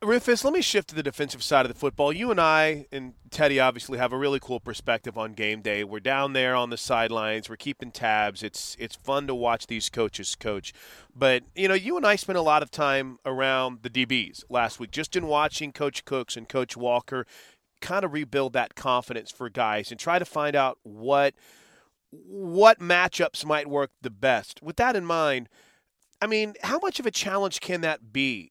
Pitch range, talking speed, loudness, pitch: 120-155 Hz, 210 wpm, -25 LUFS, 135 Hz